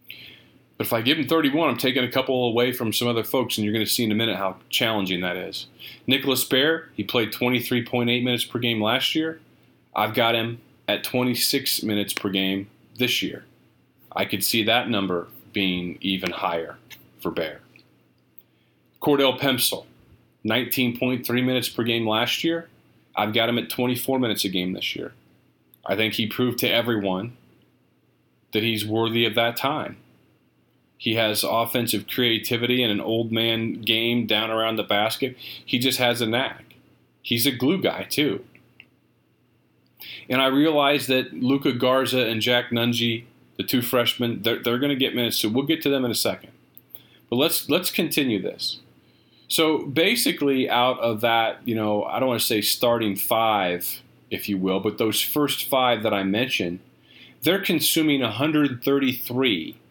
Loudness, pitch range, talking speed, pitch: -23 LUFS, 110-130 Hz, 165 wpm, 120 Hz